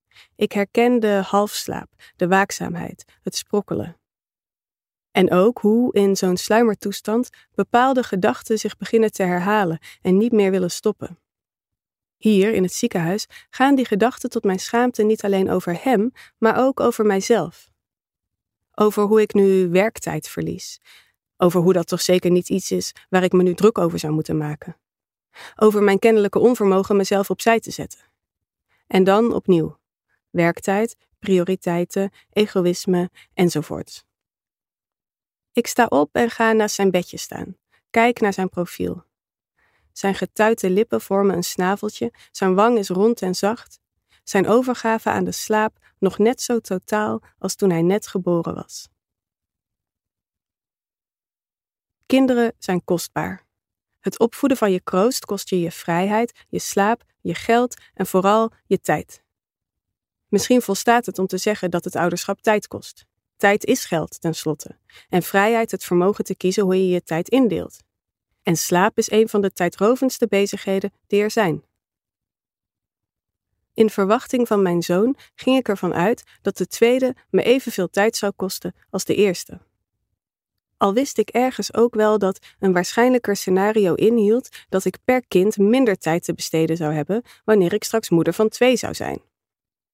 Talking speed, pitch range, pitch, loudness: 150 wpm, 180-220 Hz, 200 Hz, -20 LUFS